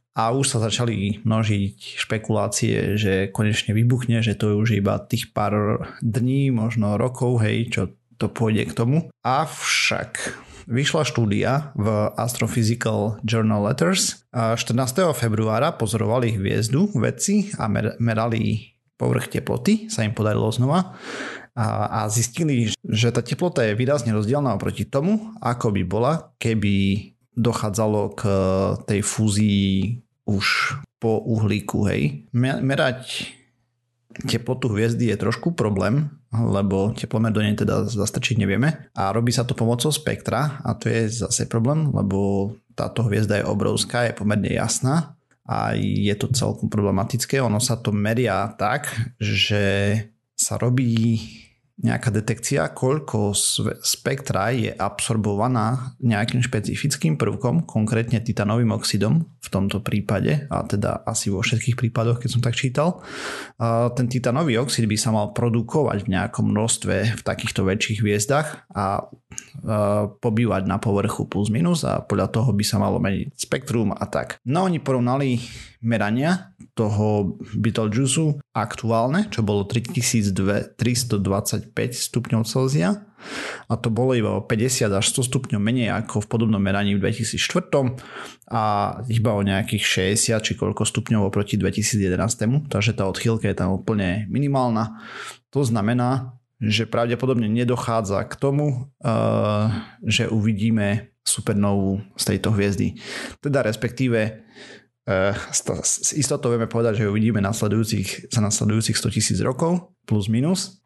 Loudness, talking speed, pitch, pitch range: -22 LUFS, 130 wpm, 115 Hz, 105-125 Hz